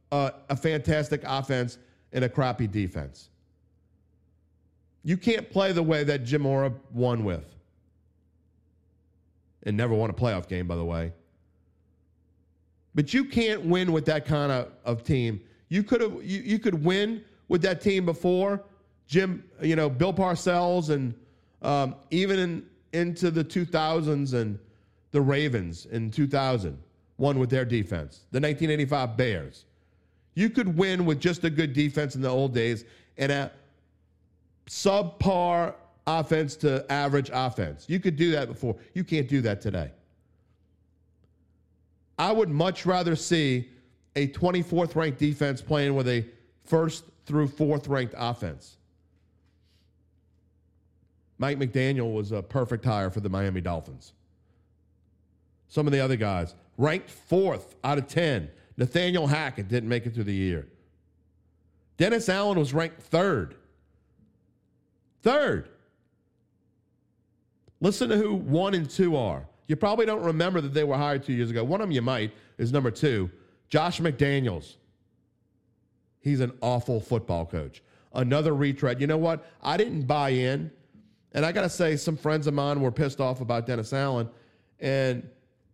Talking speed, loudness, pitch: 150 wpm, -27 LUFS, 130 Hz